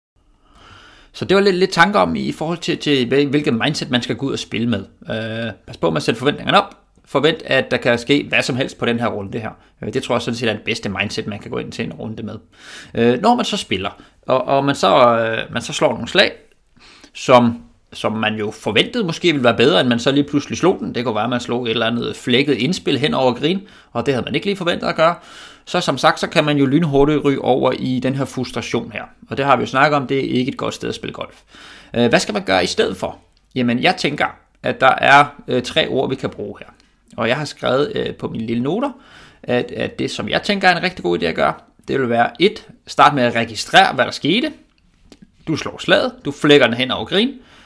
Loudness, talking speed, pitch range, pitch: -17 LUFS, 260 wpm, 120-165 Hz, 135 Hz